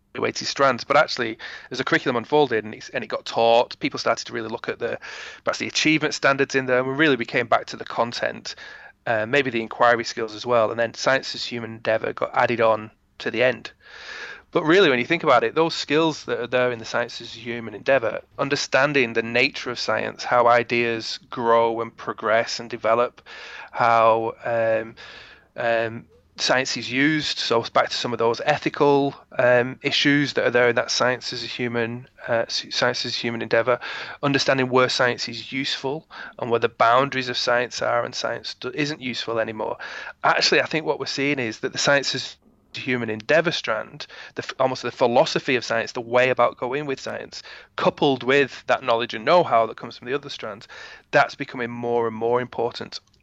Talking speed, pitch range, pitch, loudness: 195 wpm, 115-135 Hz, 120 Hz, -22 LUFS